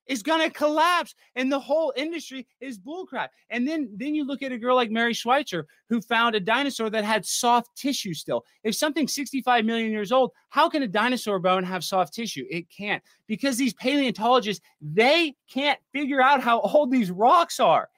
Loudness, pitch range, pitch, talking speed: -24 LUFS, 220-285 Hz, 255 Hz, 190 wpm